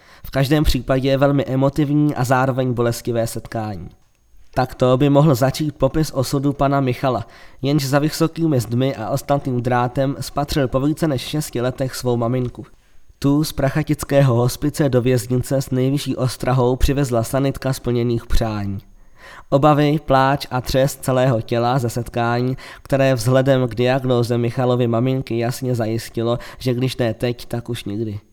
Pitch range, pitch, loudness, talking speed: 120-140 Hz, 130 Hz, -19 LUFS, 150 wpm